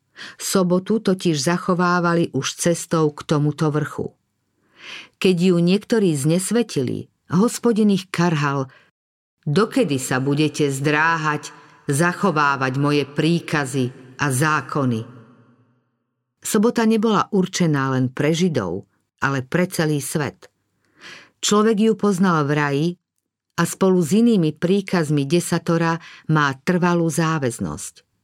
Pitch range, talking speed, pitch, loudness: 140-185 Hz, 100 wpm, 160 Hz, -20 LUFS